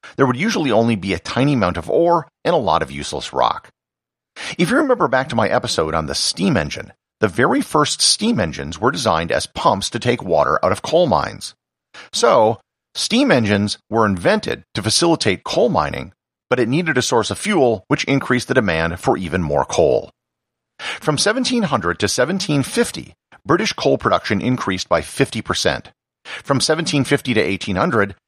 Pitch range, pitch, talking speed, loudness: 110-165 Hz, 135 Hz, 170 wpm, -18 LUFS